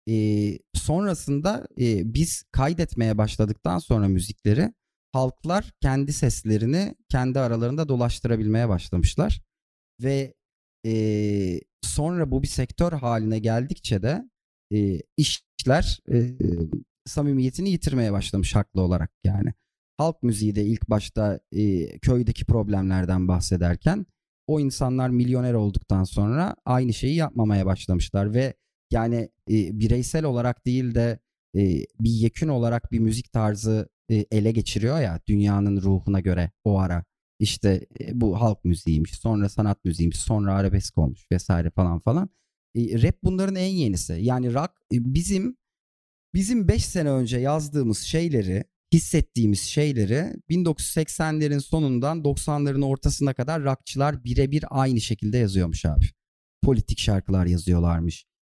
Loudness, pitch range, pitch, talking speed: -24 LUFS, 100-140 Hz, 115 Hz, 125 wpm